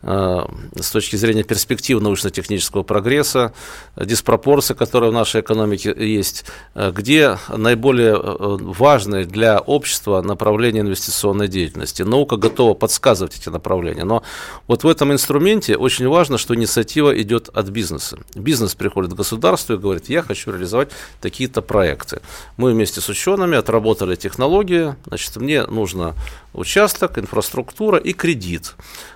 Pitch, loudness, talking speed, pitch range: 110 Hz, -17 LUFS, 125 wpm, 100-130 Hz